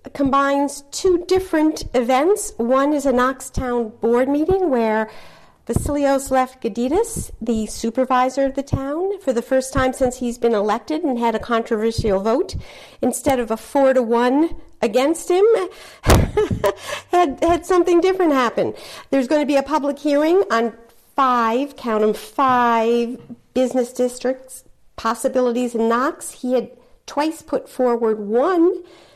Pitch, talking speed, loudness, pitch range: 260 Hz, 140 wpm, -19 LUFS, 235-300 Hz